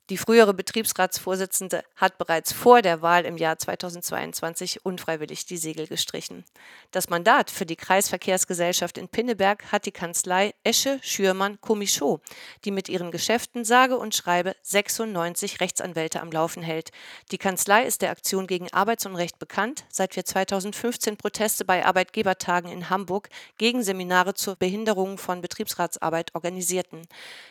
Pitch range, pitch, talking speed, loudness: 175-205 Hz, 190 Hz, 135 wpm, -24 LUFS